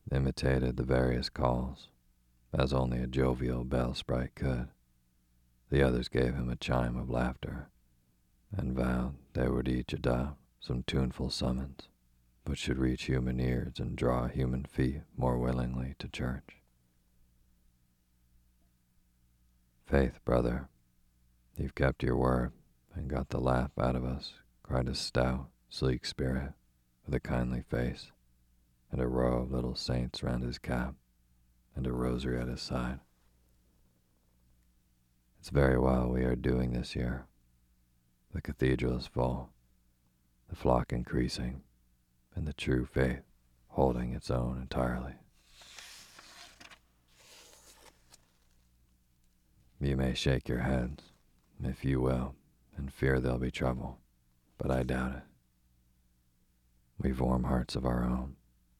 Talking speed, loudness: 125 wpm, -33 LUFS